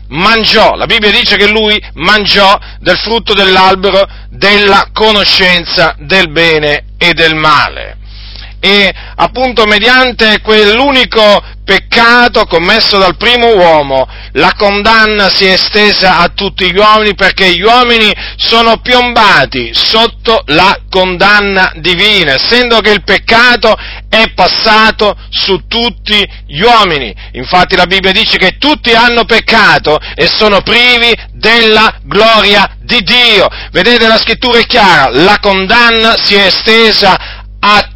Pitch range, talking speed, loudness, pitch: 185-225 Hz, 130 wpm, -6 LUFS, 205 Hz